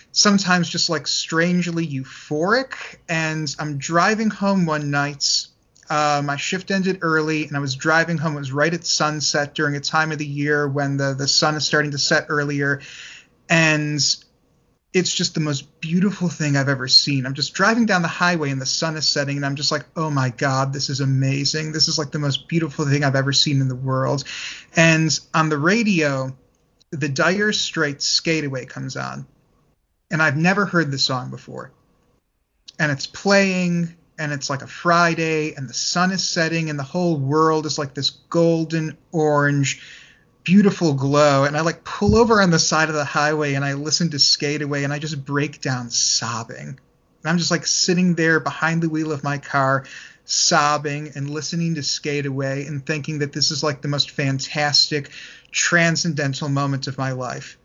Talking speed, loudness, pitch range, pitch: 190 wpm, -20 LUFS, 140-165 Hz, 150 Hz